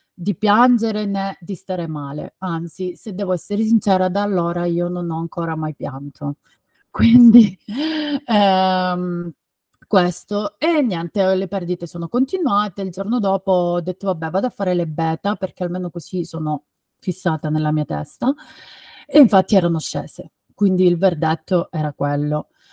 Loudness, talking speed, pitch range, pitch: -19 LUFS, 150 wpm, 165-205 Hz, 185 Hz